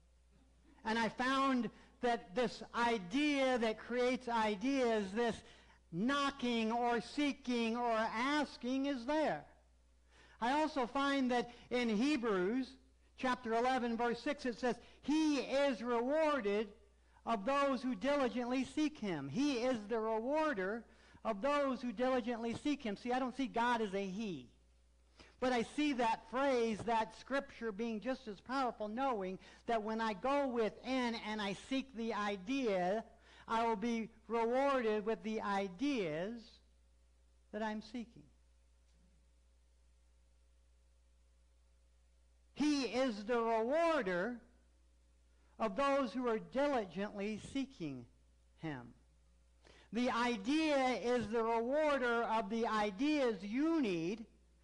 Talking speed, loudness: 120 wpm, -37 LUFS